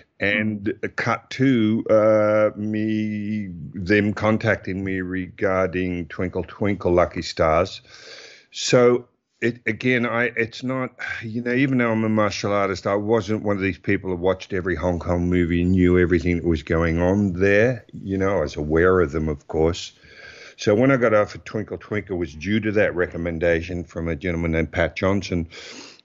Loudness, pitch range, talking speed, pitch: -22 LUFS, 90-110 Hz, 175 wpm, 100 Hz